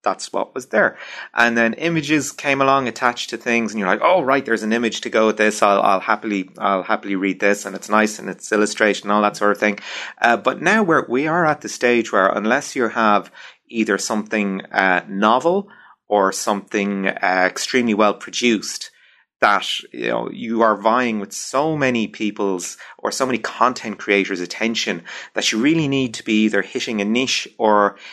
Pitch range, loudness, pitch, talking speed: 100-120 Hz, -19 LUFS, 110 Hz, 200 wpm